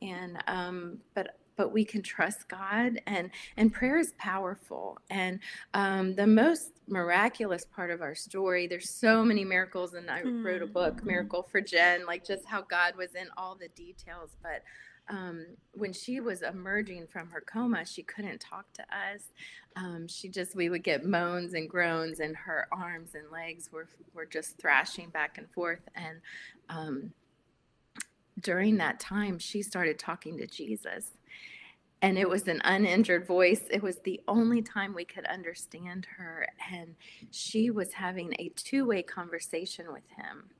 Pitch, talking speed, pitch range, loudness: 185 Hz, 165 wpm, 175-205 Hz, -31 LUFS